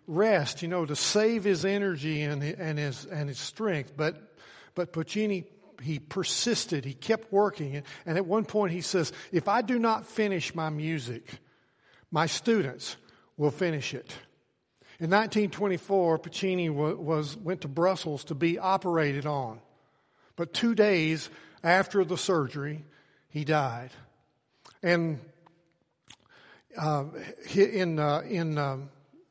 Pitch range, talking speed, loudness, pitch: 150-195 Hz, 130 wpm, -29 LUFS, 165 Hz